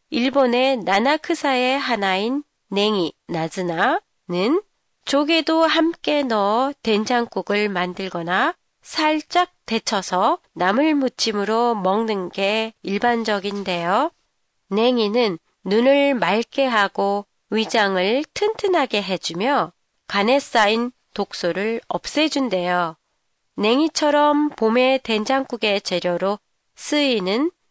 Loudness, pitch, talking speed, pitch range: -20 LUFS, 225 Hz, 215 characters per minute, 200-280 Hz